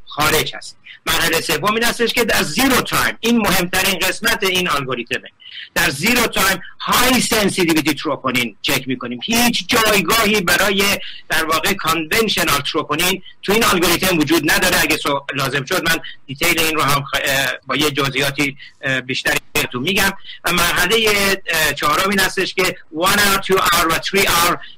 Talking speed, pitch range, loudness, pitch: 145 wpm, 150-195 Hz, -16 LUFS, 175 Hz